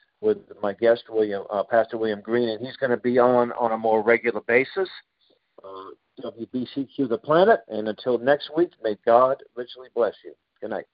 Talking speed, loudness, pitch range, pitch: 185 wpm, -23 LUFS, 110-130 Hz, 120 Hz